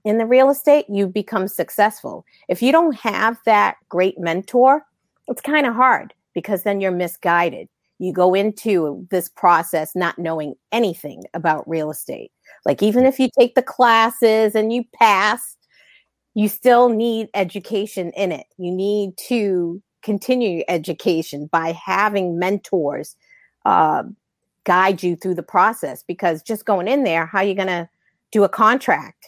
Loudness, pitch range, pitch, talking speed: -18 LUFS, 175-230 Hz, 200 Hz, 160 wpm